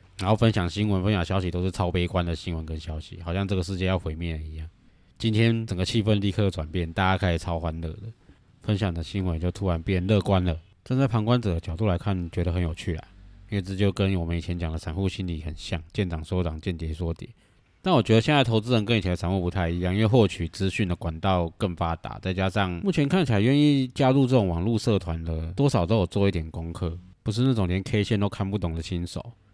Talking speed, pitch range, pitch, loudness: 360 characters per minute, 85-105 Hz, 95 Hz, -26 LUFS